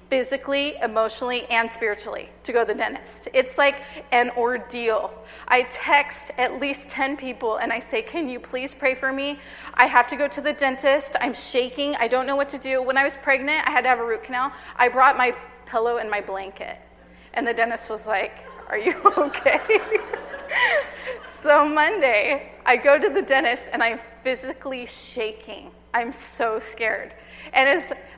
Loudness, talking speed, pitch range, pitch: -22 LUFS, 180 wpm, 235-285 Hz, 260 Hz